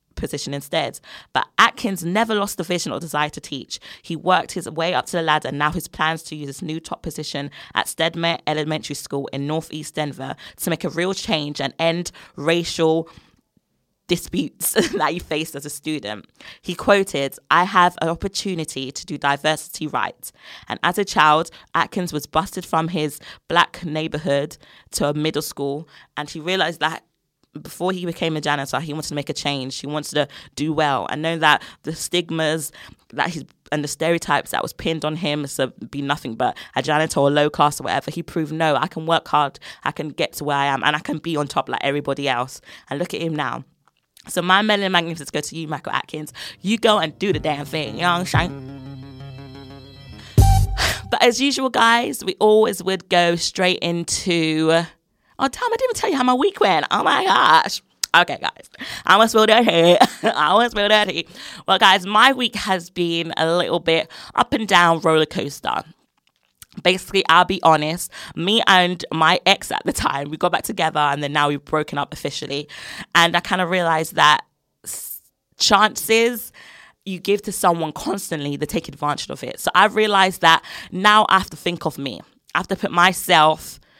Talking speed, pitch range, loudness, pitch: 195 wpm, 150-185 Hz, -19 LUFS, 160 Hz